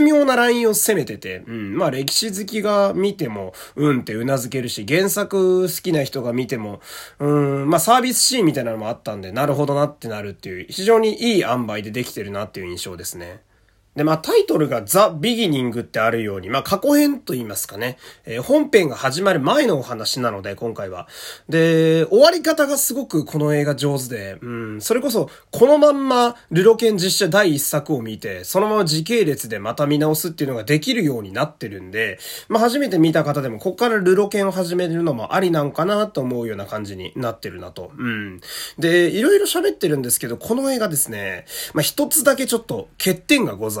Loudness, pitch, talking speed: -19 LUFS, 155 Hz, 420 characters per minute